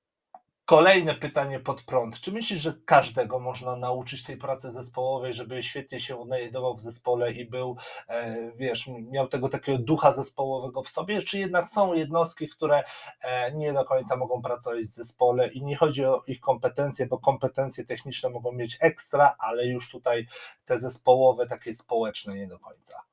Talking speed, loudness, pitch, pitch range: 165 wpm, -27 LUFS, 130 Hz, 125-145 Hz